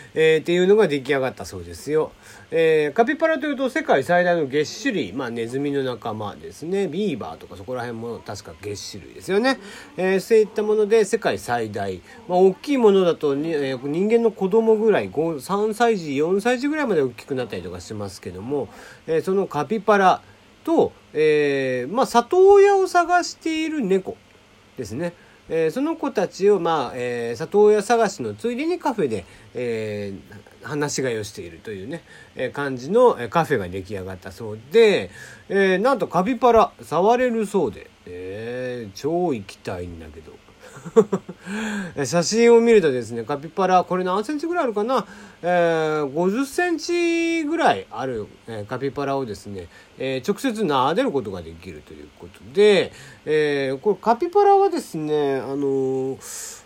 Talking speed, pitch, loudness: 335 characters per minute, 175 Hz, -21 LUFS